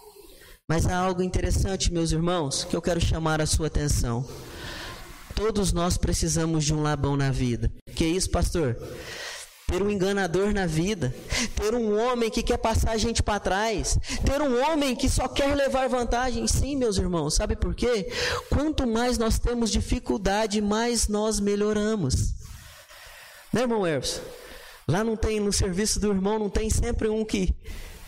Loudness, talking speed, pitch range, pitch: -26 LUFS, 165 wpm, 165-235 Hz, 210 Hz